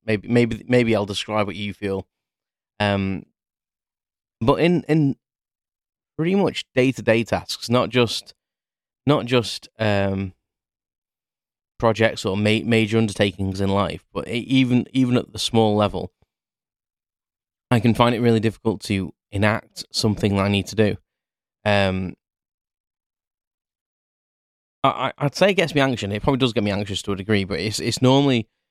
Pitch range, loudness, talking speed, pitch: 100-120 Hz, -21 LUFS, 150 wpm, 110 Hz